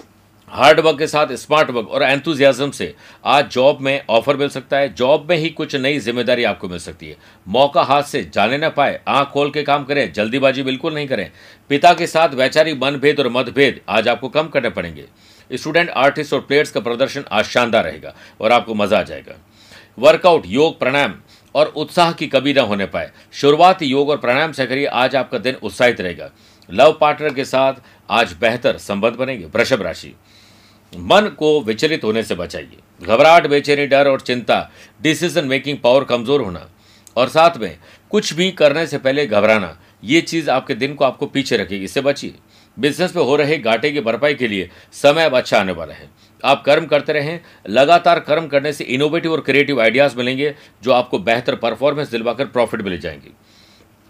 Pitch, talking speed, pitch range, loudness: 140 Hz, 190 wpm, 115-150 Hz, -16 LUFS